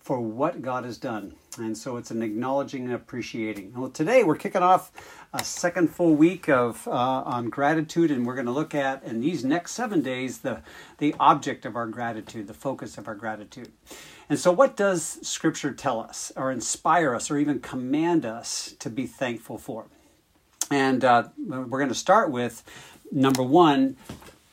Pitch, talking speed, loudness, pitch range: 135 Hz, 180 wpm, -25 LUFS, 120-155 Hz